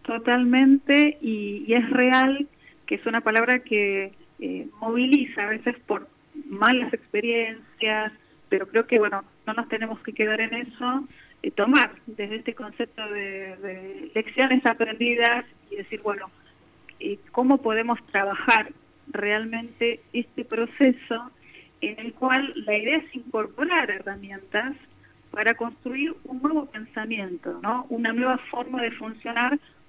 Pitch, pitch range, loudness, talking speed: 235 Hz, 215-255 Hz, -24 LUFS, 135 wpm